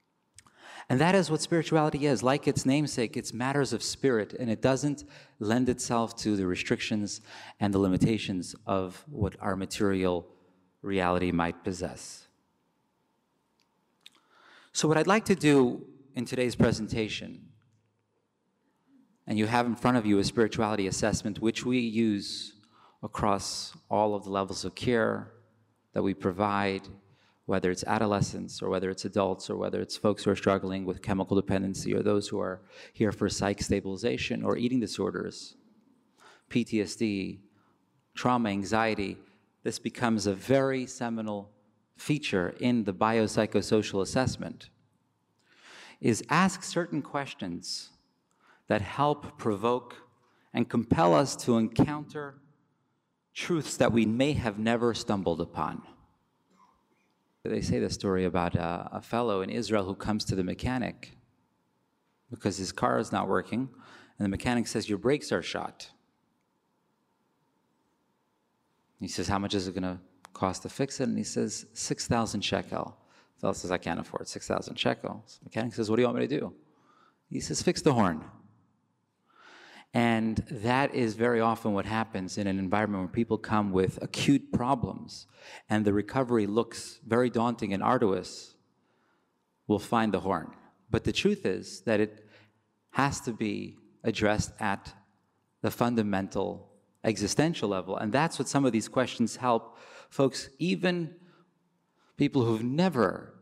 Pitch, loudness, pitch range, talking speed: 110 Hz, -29 LUFS, 100-125 Hz, 145 wpm